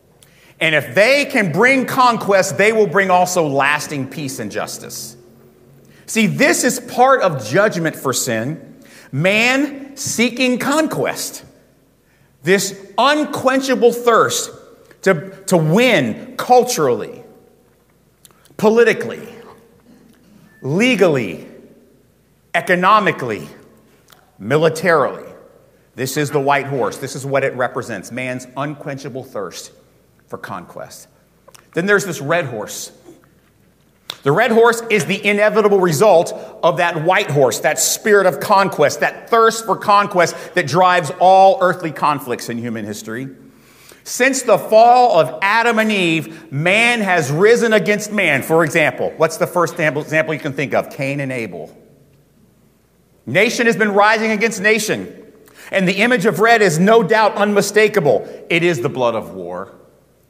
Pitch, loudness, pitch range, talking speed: 195 Hz, -15 LUFS, 155-230 Hz, 130 wpm